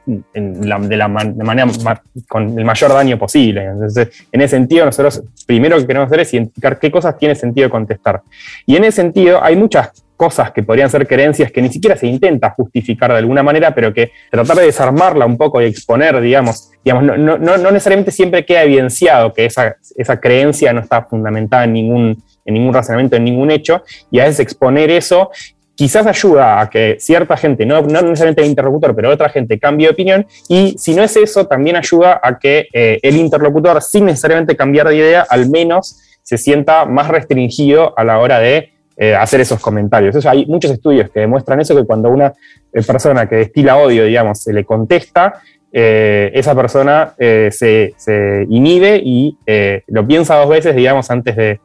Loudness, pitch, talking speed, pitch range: -10 LUFS, 135 Hz, 200 wpm, 115-155 Hz